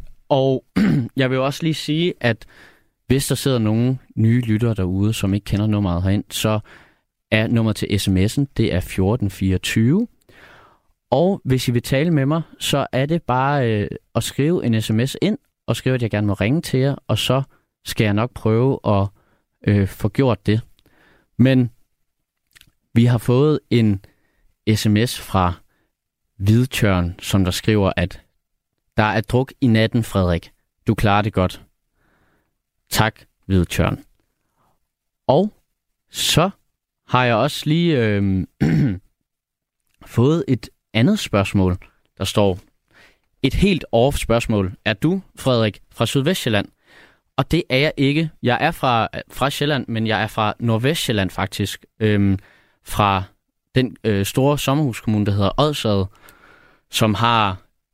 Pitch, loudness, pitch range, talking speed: 110 Hz, -19 LUFS, 100-130 Hz, 145 wpm